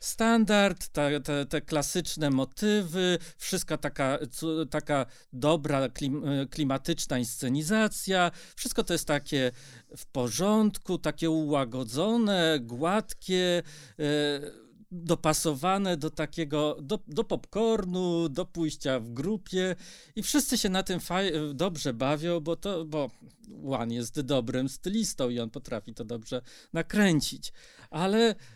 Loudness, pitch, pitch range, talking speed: -29 LUFS, 160 Hz, 140-185 Hz, 110 wpm